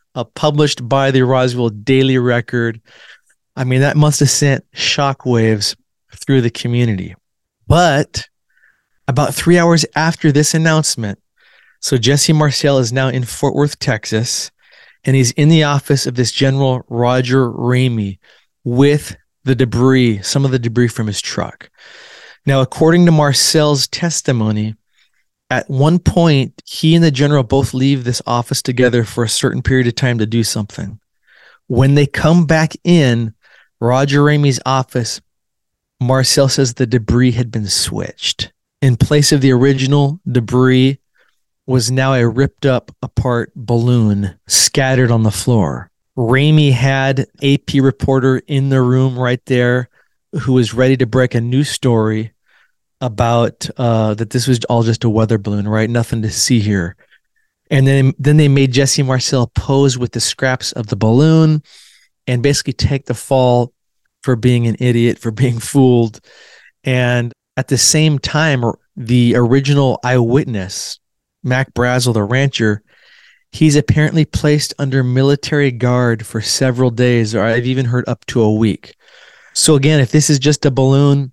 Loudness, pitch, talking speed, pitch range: -14 LUFS, 130 Hz, 155 wpm, 120-140 Hz